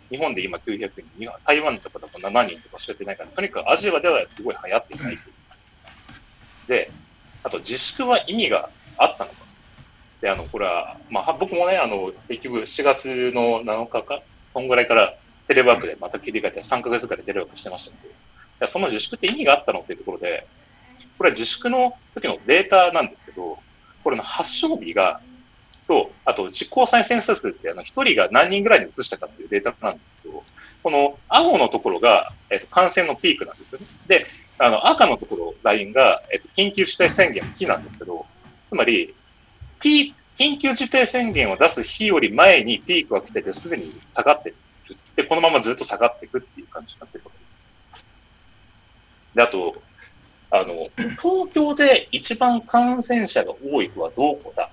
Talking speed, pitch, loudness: 360 characters per minute, 255 Hz, -20 LUFS